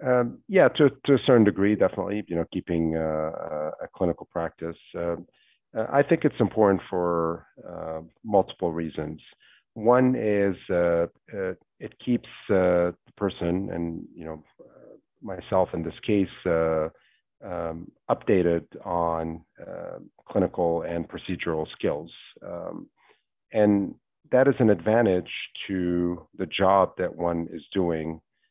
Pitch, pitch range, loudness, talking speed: 90 Hz, 85-105 Hz, -25 LUFS, 135 wpm